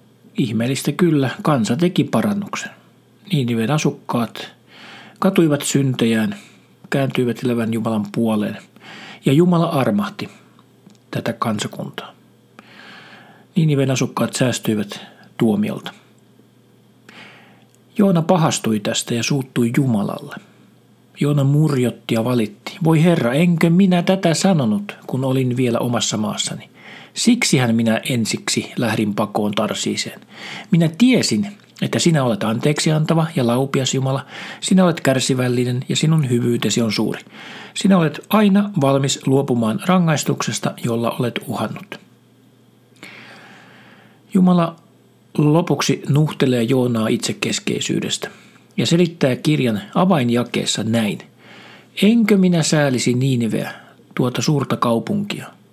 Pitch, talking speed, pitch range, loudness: 140 Hz, 100 wpm, 120-170 Hz, -18 LUFS